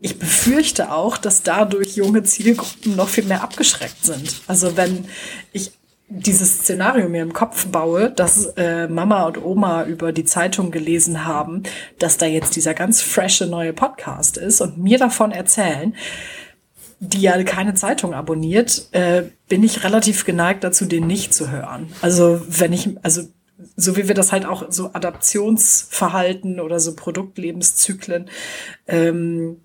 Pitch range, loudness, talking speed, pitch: 170-205 Hz, -17 LUFS, 150 wpm, 185 Hz